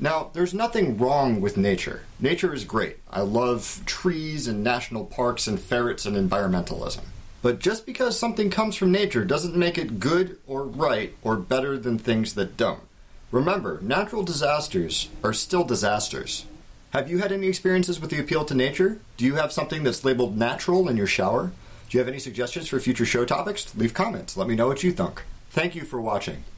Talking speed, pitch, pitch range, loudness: 190 wpm, 135 Hz, 120-180 Hz, -25 LUFS